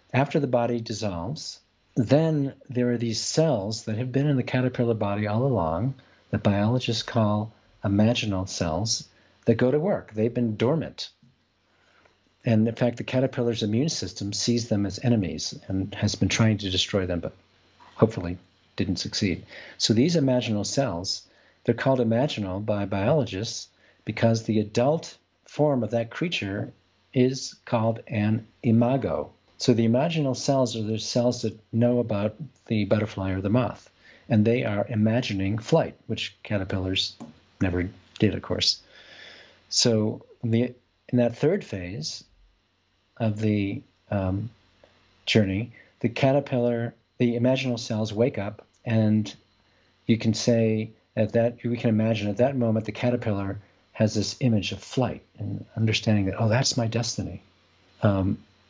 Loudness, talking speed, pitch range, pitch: -25 LUFS, 145 wpm, 100-120 Hz, 110 Hz